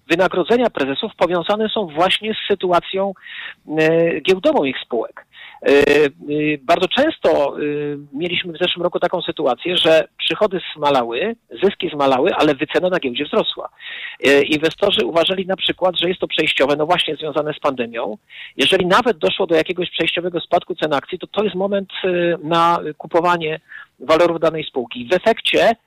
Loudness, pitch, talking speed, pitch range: -18 LUFS, 170 Hz, 155 wpm, 155-185 Hz